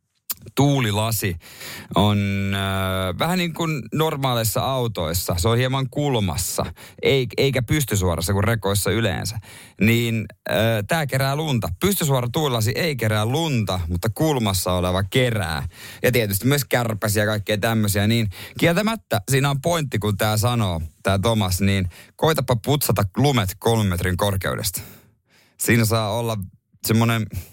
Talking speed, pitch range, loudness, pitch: 125 wpm, 100-130 Hz, -21 LUFS, 115 Hz